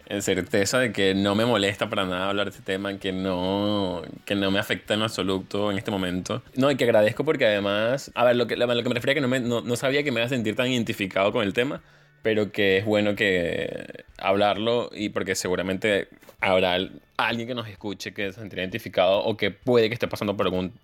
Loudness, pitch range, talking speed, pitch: -24 LUFS, 95-120 Hz, 230 wpm, 105 Hz